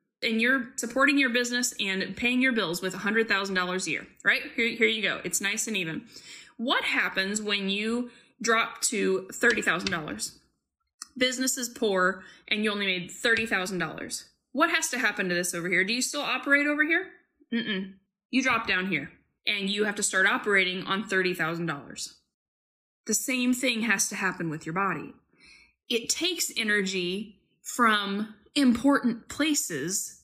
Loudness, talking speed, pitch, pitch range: -26 LUFS, 155 wpm, 215 Hz, 190-250 Hz